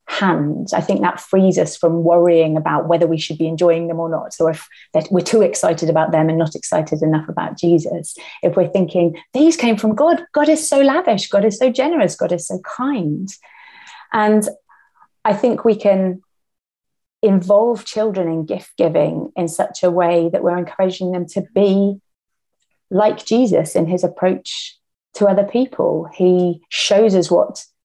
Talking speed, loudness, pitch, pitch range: 175 wpm, -17 LUFS, 190 Hz, 170-220 Hz